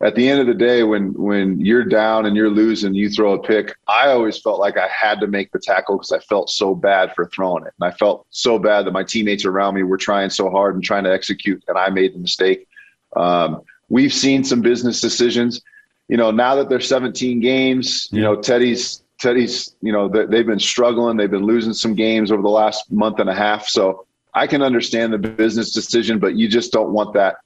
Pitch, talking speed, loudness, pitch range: 110 Hz, 230 wpm, -17 LUFS, 100-120 Hz